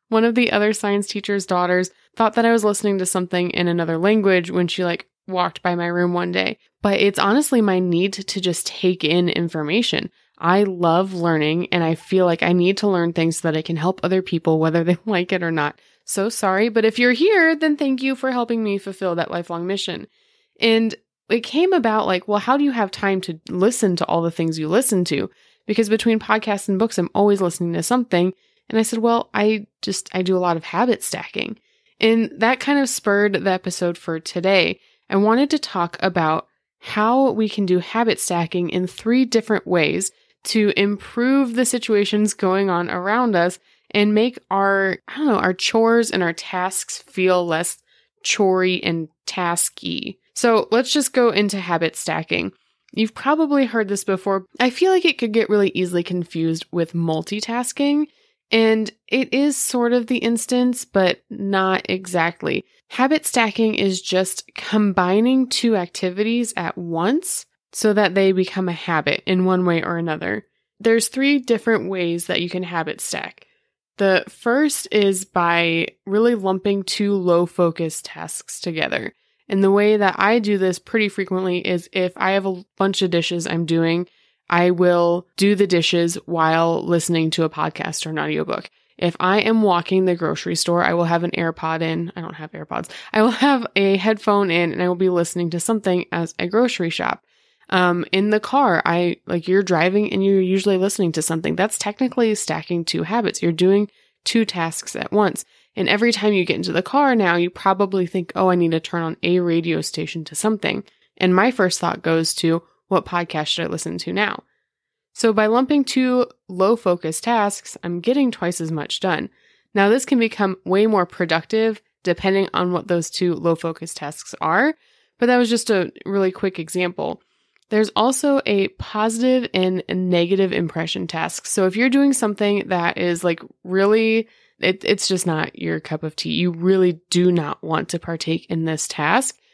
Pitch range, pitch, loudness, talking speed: 175-225 Hz, 190 Hz, -19 LUFS, 190 wpm